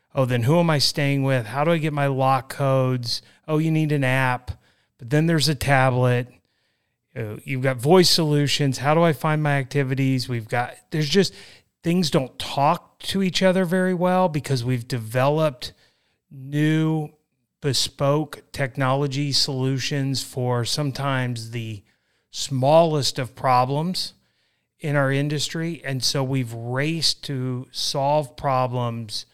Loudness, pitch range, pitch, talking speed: -22 LUFS, 130-155 Hz, 140 Hz, 140 wpm